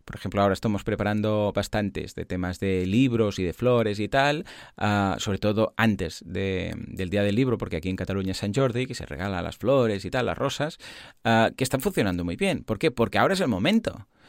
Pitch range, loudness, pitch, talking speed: 95-115 Hz, -25 LUFS, 105 Hz, 225 wpm